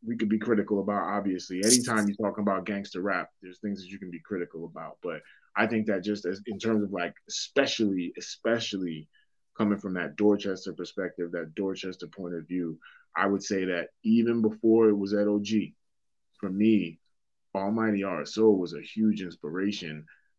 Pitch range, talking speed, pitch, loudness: 90-110 Hz, 175 wpm, 100 Hz, -28 LUFS